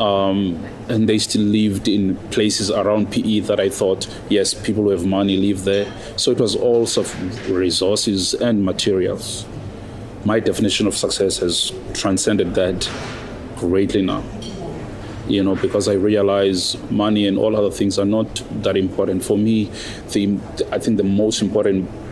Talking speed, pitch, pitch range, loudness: 160 wpm, 105 Hz, 100-110 Hz, -19 LUFS